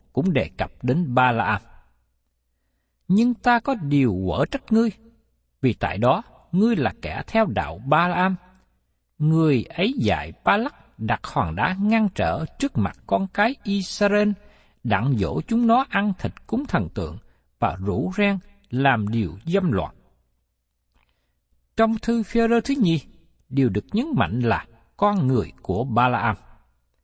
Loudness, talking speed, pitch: -23 LUFS, 160 wpm, 140 Hz